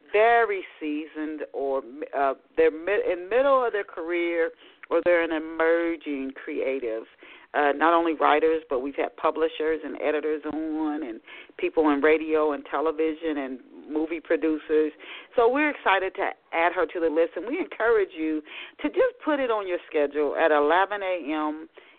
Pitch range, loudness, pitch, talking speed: 155-235 Hz, -25 LUFS, 165 Hz, 165 wpm